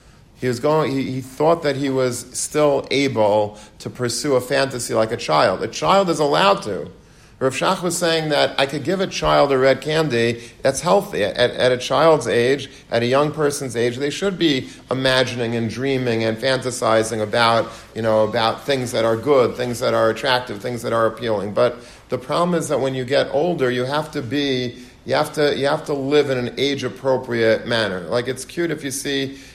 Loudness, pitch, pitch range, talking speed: -19 LUFS, 130 Hz, 120-145 Hz, 210 wpm